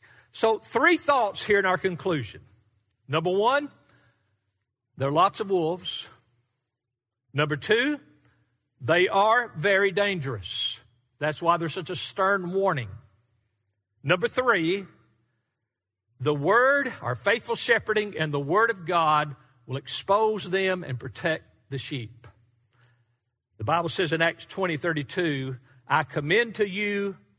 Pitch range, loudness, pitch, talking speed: 120-195 Hz, -25 LUFS, 150 Hz, 125 wpm